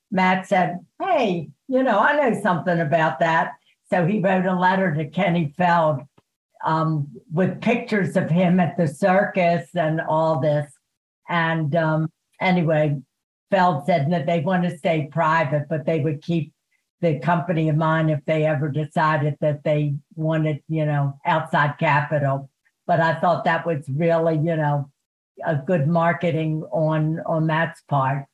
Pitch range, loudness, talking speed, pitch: 155-180 Hz, -21 LUFS, 155 wpm, 165 Hz